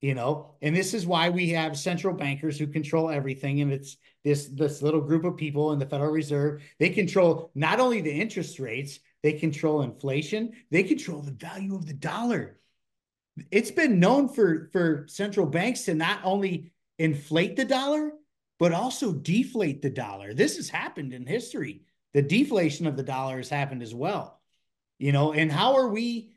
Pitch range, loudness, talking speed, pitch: 145-195 Hz, -27 LUFS, 180 wpm, 160 Hz